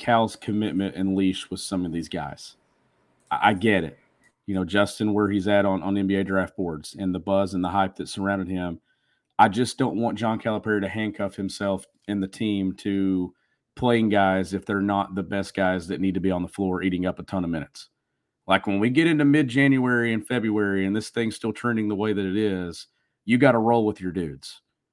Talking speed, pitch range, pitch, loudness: 220 wpm, 95-110 Hz, 100 Hz, -24 LUFS